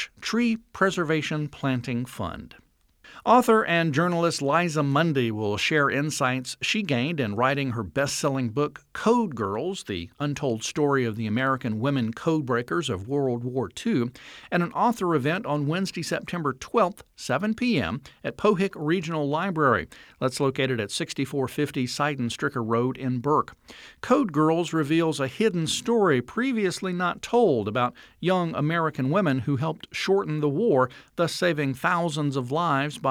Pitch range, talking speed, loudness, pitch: 130-175 Hz, 145 wpm, -25 LUFS, 150 Hz